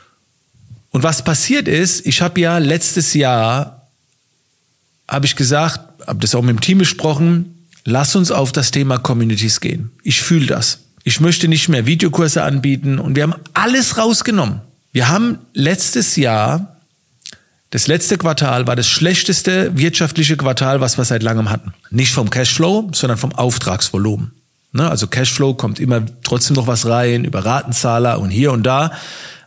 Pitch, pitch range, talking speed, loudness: 140 Hz, 125-165 Hz, 155 wpm, -14 LUFS